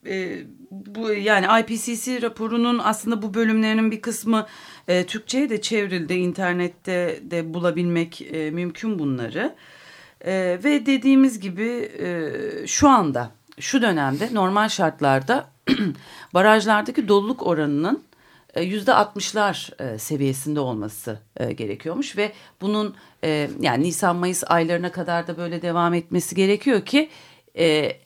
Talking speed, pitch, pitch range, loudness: 120 wpm, 195 Hz, 170-225 Hz, -22 LUFS